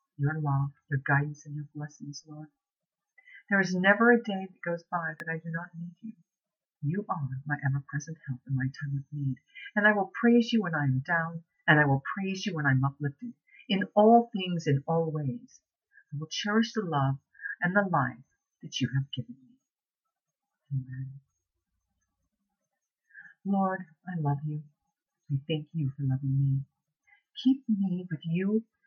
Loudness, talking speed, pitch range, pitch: -29 LUFS, 175 wpm, 140-200 Hz, 160 Hz